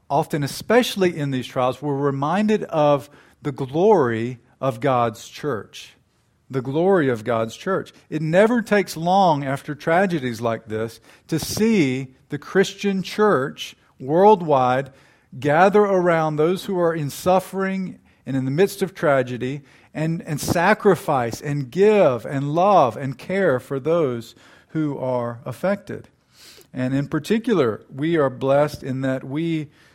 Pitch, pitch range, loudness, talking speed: 150 Hz, 130-185 Hz, -21 LUFS, 135 wpm